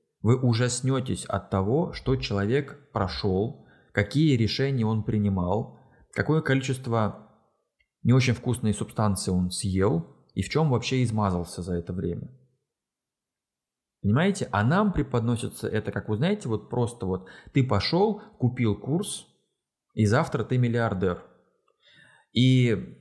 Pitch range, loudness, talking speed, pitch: 100-135 Hz, -26 LUFS, 125 wpm, 120 Hz